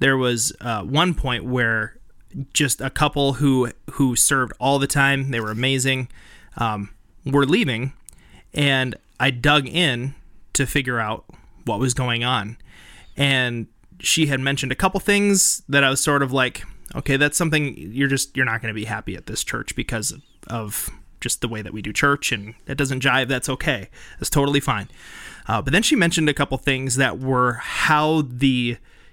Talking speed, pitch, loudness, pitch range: 185 wpm, 130 Hz, -20 LUFS, 115-140 Hz